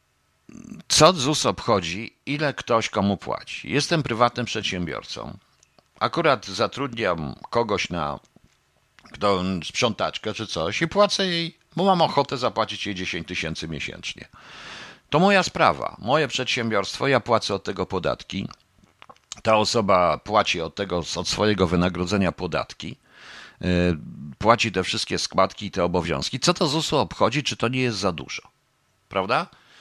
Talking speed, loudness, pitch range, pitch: 135 wpm, -23 LUFS, 90-125 Hz, 105 Hz